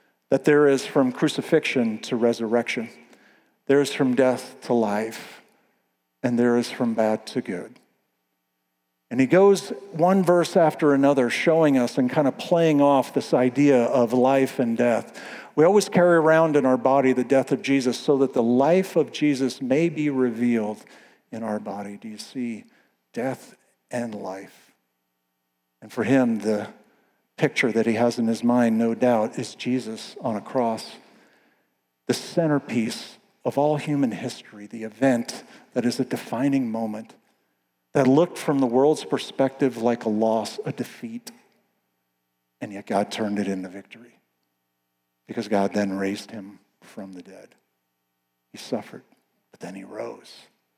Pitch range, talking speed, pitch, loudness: 105-140 Hz, 155 wpm, 120 Hz, -22 LUFS